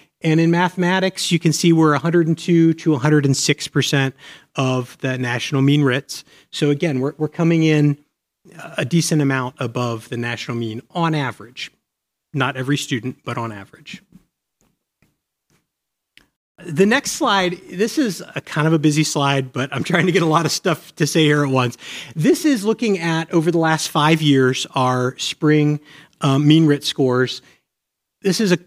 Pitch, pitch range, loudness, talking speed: 150 Hz, 135-170 Hz, -18 LUFS, 165 wpm